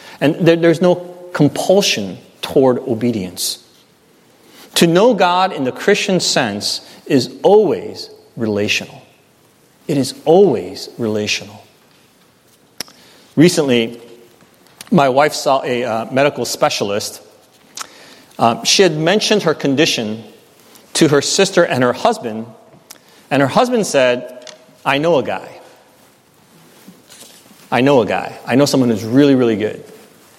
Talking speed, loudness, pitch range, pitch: 115 wpm, -15 LUFS, 120-180 Hz, 140 Hz